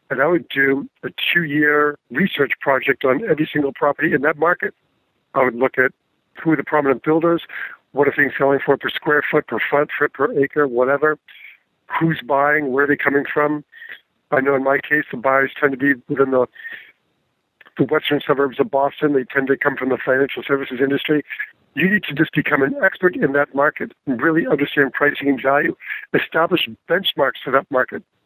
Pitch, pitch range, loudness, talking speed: 140 Hz, 135-150 Hz, -18 LUFS, 195 wpm